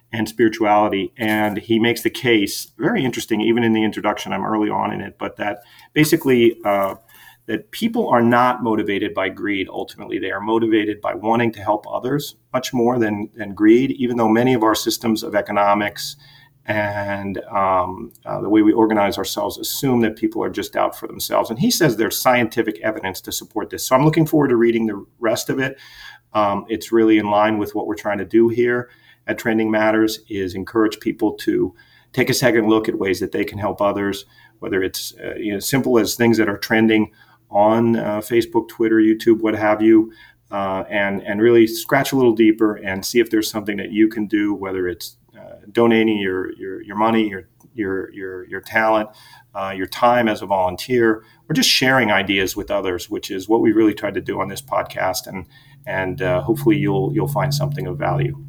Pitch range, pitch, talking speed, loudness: 105-120 Hz, 110 Hz, 205 wpm, -19 LUFS